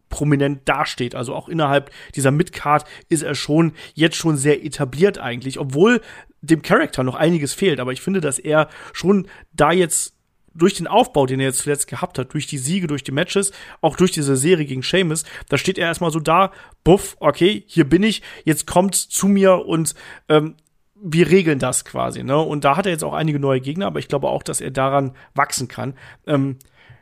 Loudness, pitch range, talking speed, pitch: -19 LUFS, 140-175 Hz, 200 wpm, 155 Hz